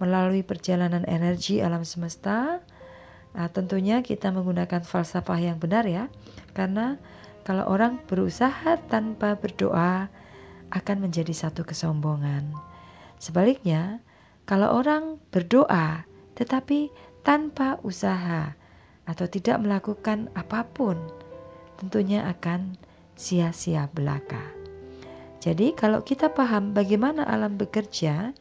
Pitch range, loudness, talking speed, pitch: 170-215 Hz, -26 LUFS, 95 wpm, 190 Hz